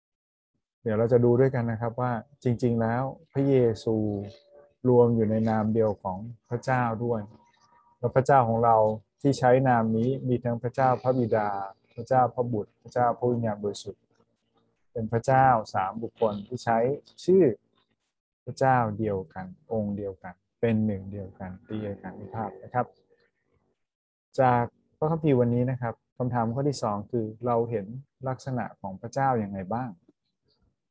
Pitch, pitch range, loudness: 115 Hz, 110-125 Hz, -26 LUFS